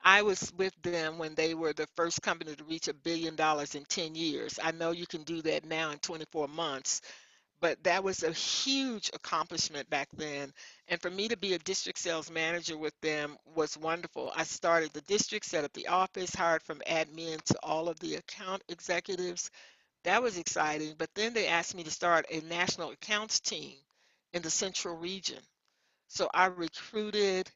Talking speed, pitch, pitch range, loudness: 190 wpm, 170 Hz, 160-185 Hz, -33 LUFS